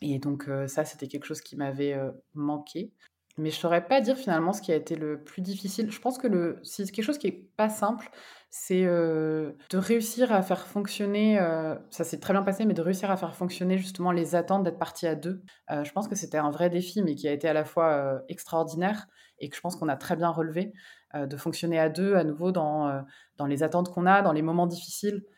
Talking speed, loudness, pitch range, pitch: 250 wpm, -28 LUFS, 155-195 Hz, 175 Hz